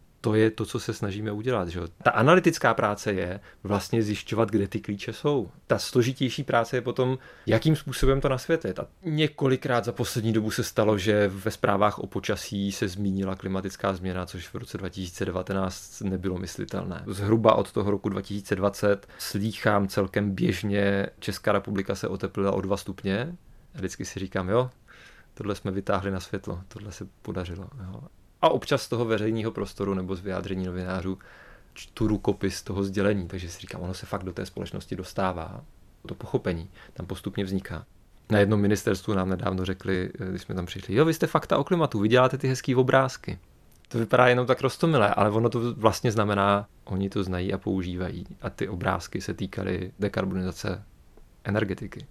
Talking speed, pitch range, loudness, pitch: 175 wpm, 95-115 Hz, -27 LUFS, 100 Hz